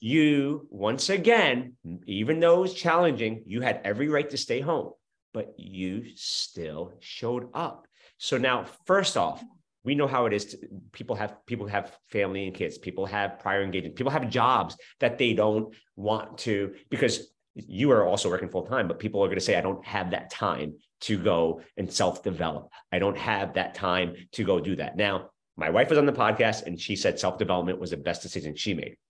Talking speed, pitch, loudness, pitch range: 200 wpm, 110 Hz, -27 LUFS, 95-140 Hz